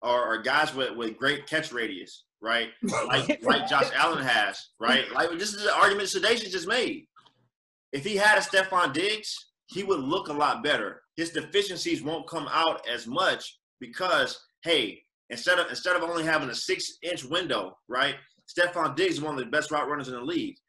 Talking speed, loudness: 190 wpm, -26 LUFS